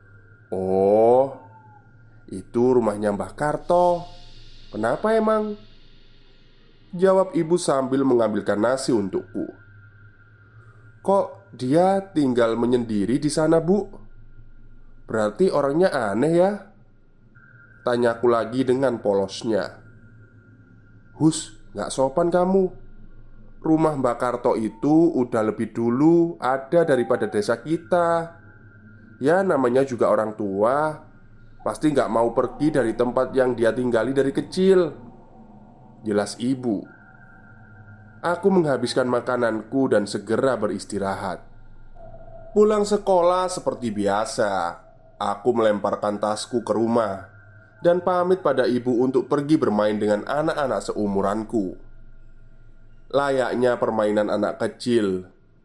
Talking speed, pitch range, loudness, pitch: 95 wpm, 110-140 Hz, -22 LUFS, 115 Hz